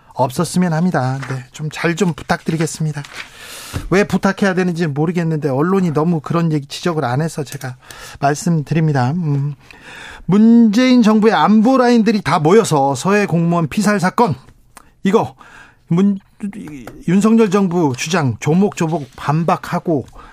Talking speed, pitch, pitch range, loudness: 295 characters per minute, 170 Hz, 150-195 Hz, -15 LUFS